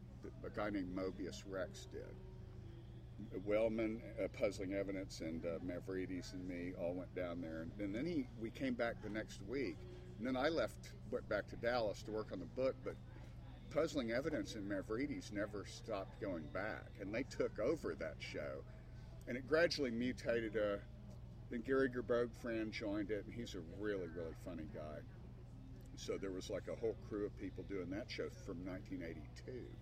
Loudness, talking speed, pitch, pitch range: -44 LUFS, 180 wpm, 105 Hz, 95-120 Hz